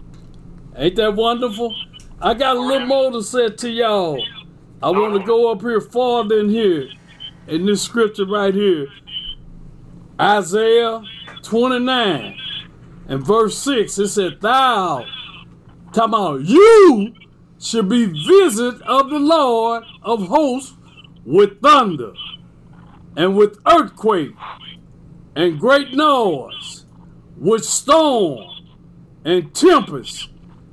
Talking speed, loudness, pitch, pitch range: 110 wpm, -16 LUFS, 220 Hz, 175-245 Hz